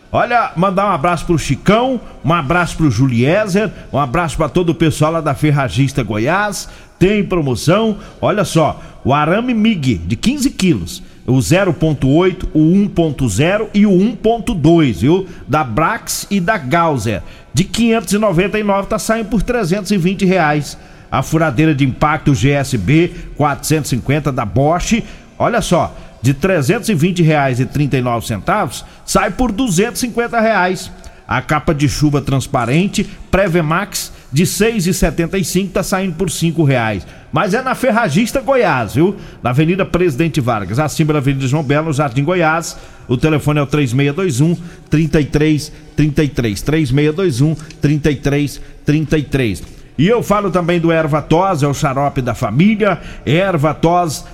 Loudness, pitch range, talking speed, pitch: -15 LUFS, 145-190 Hz, 135 wpm, 165 Hz